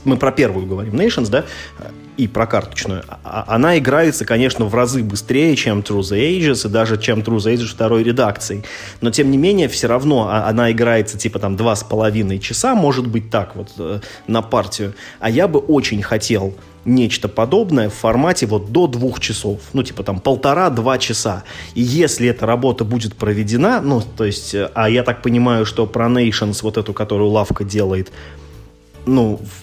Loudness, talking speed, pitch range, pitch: -16 LUFS, 175 wpm, 105-125 Hz, 115 Hz